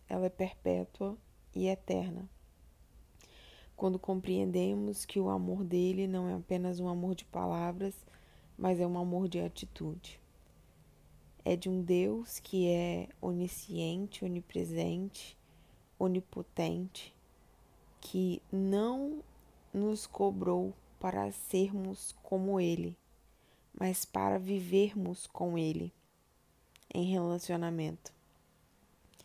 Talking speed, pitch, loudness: 100 wpm, 180 Hz, -35 LUFS